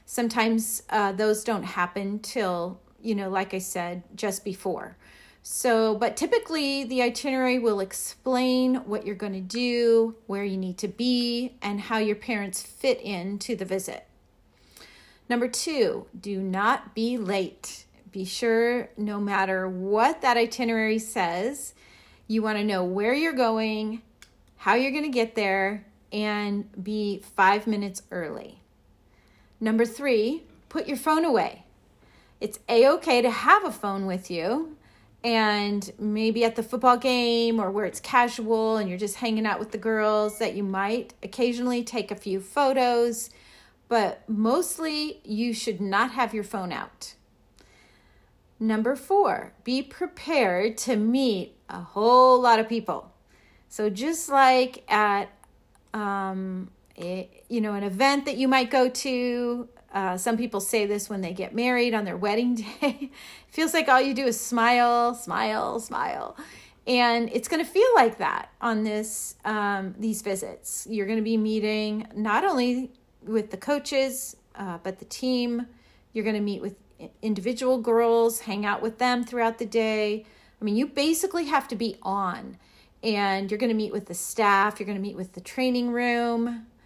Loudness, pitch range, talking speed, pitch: -25 LUFS, 205-245 Hz, 160 wpm, 225 Hz